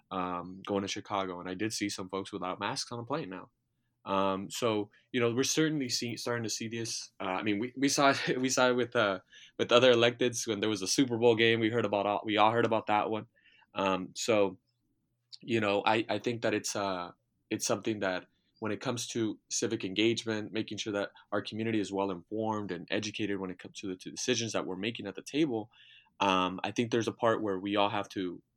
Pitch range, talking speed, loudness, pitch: 100-120 Hz, 235 wpm, -31 LUFS, 110 Hz